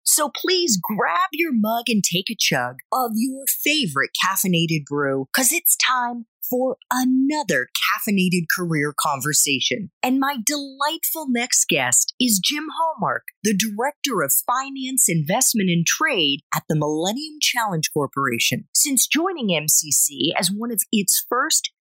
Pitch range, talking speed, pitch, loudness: 165-270 Hz, 140 wpm, 225 Hz, -20 LUFS